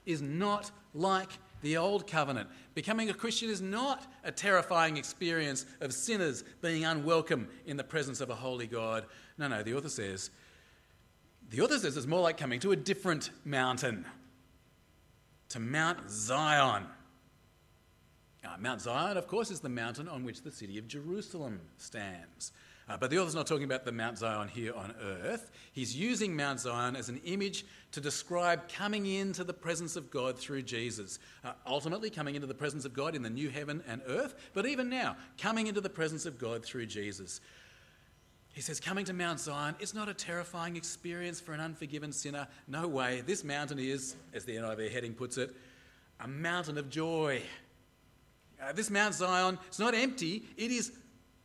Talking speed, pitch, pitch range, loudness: 180 wpm, 150 Hz, 125-185 Hz, -35 LUFS